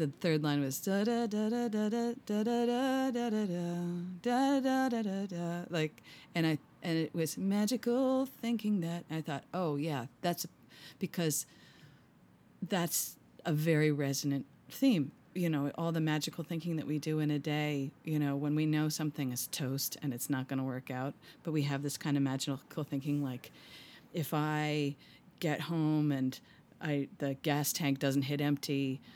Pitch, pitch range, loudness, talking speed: 155 Hz, 145-185 Hz, -34 LUFS, 165 wpm